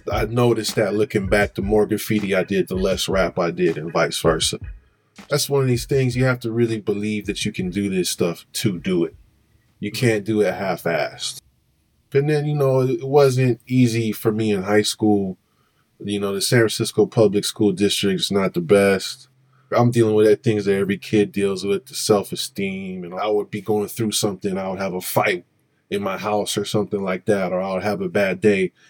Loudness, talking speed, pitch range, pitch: -20 LUFS, 220 wpm, 100-115 Hz, 105 Hz